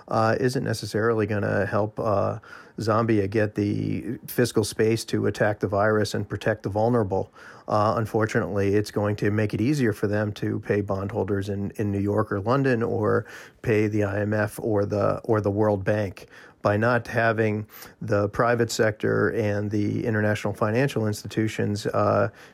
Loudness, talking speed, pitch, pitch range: -24 LUFS, 160 wpm, 105 Hz, 105-115 Hz